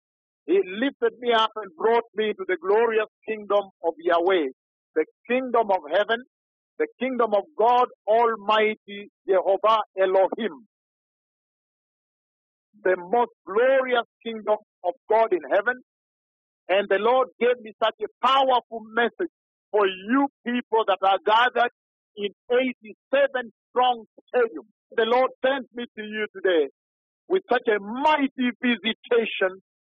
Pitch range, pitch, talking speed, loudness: 205-250 Hz, 230 Hz, 125 wpm, -24 LUFS